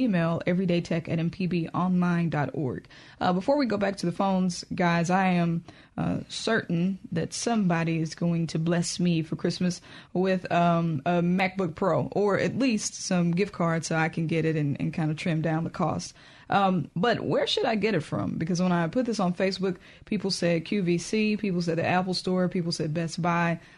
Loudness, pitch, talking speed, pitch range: -27 LUFS, 175 Hz, 195 wpm, 165-190 Hz